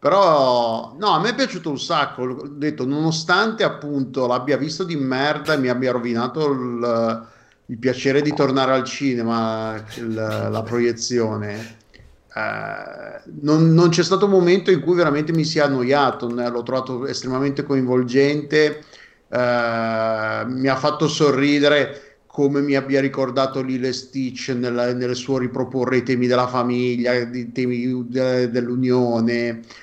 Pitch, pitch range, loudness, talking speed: 130 Hz, 120-145 Hz, -20 LUFS, 145 wpm